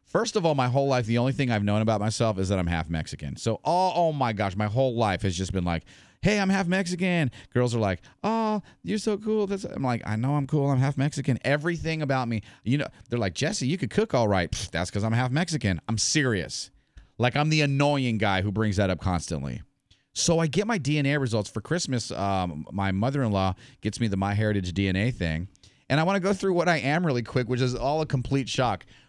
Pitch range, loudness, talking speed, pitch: 100-150 Hz, -26 LUFS, 245 wpm, 125 Hz